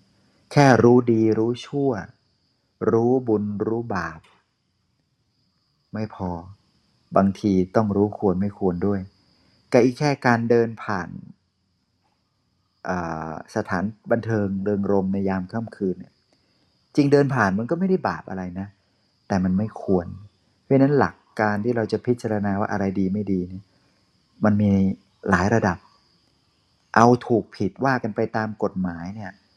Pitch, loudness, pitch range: 105 Hz, -22 LUFS, 95-115 Hz